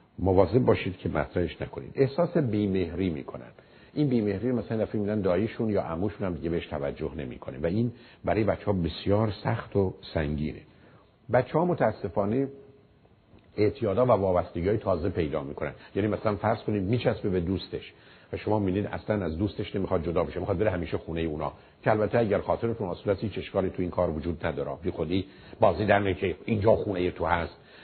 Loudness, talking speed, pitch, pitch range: -28 LUFS, 175 wpm, 100 Hz, 90-110 Hz